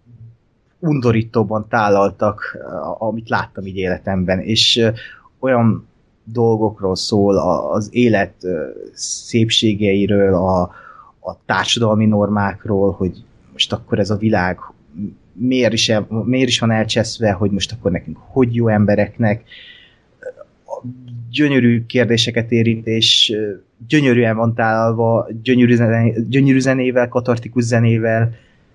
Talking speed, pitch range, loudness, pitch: 105 wpm, 105-120 Hz, -16 LUFS, 115 Hz